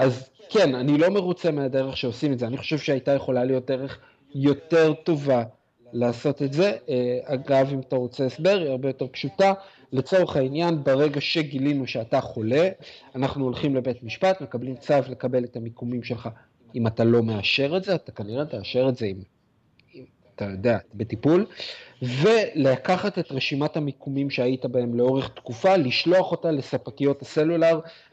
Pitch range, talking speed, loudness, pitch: 125-155 Hz, 155 wpm, -24 LUFS, 135 Hz